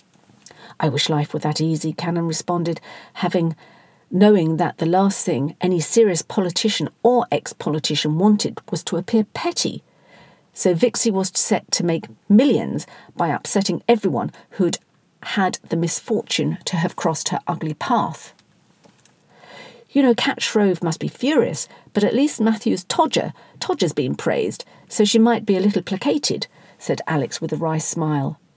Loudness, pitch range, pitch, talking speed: -20 LUFS, 165-225 Hz, 185 Hz, 150 wpm